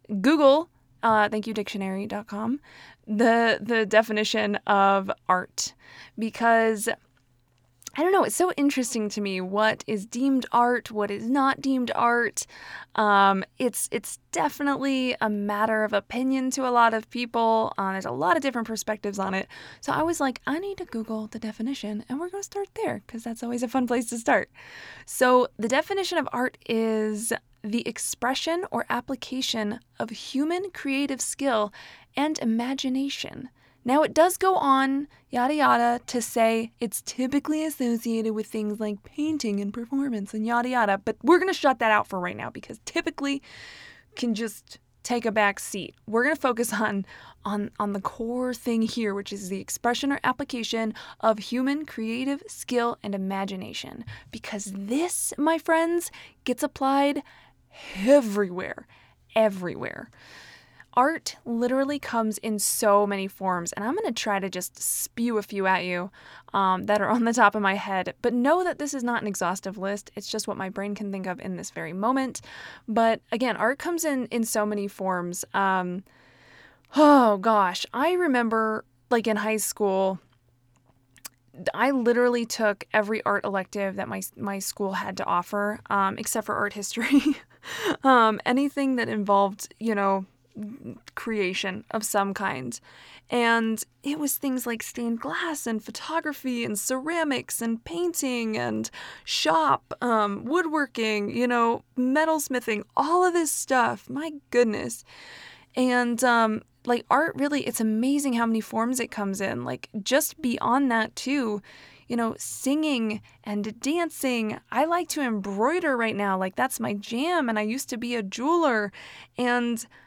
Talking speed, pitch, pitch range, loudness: 160 wpm, 230 Hz, 210-270 Hz, -25 LUFS